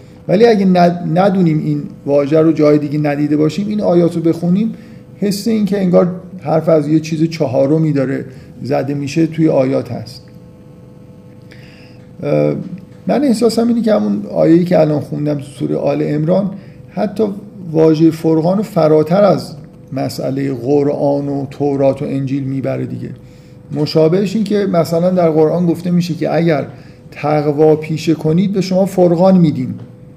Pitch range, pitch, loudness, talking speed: 150-185 Hz, 160 Hz, -14 LUFS, 145 wpm